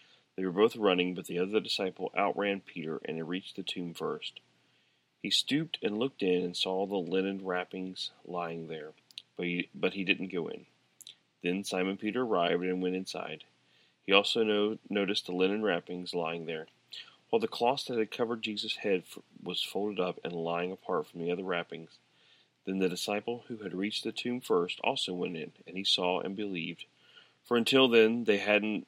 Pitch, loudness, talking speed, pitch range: 95 Hz, -32 LUFS, 190 wpm, 90-105 Hz